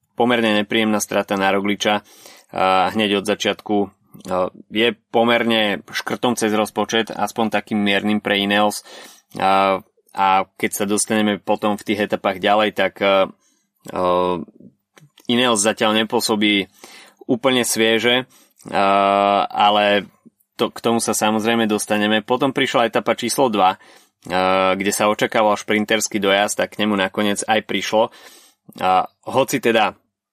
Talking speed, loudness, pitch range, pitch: 115 wpm, -18 LUFS, 100-115 Hz, 105 Hz